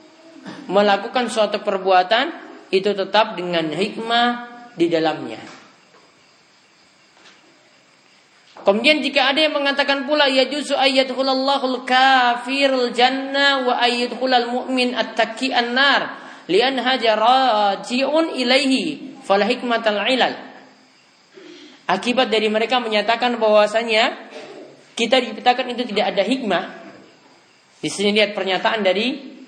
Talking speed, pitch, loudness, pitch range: 75 wpm, 245 Hz, -18 LUFS, 215-270 Hz